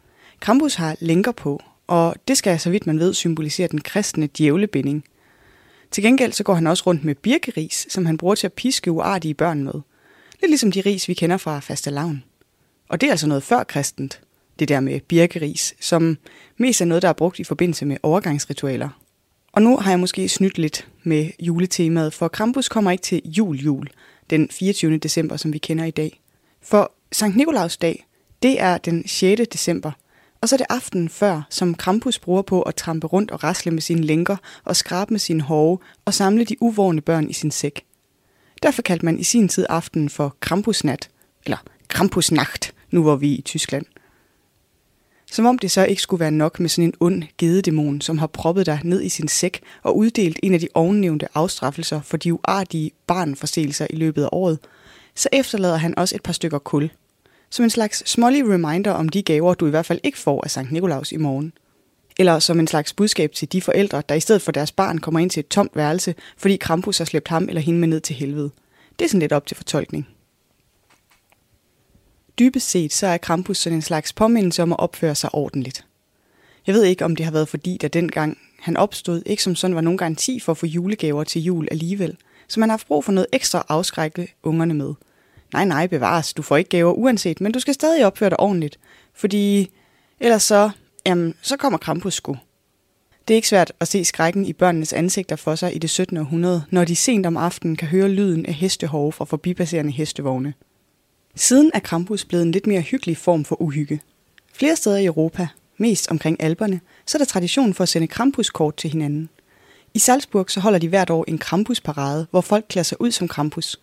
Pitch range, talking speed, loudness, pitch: 155-195 Hz, 205 wpm, -20 LUFS, 170 Hz